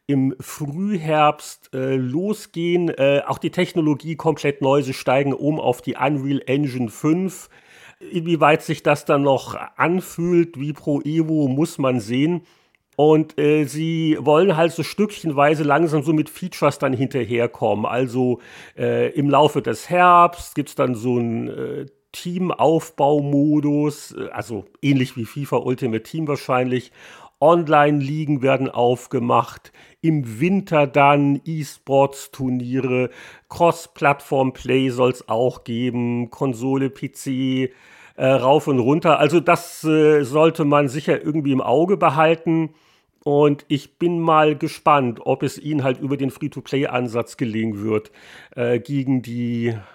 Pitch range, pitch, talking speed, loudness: 130-155 Hz, 145 Hz, 130 wpm, -20 LUFS